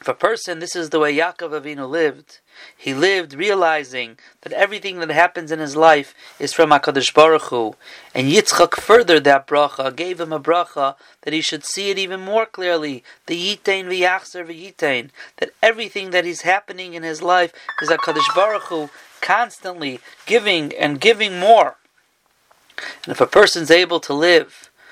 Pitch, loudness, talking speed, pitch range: 170 Hz, -17 LUFS, 170 wpm, 150-195 Hz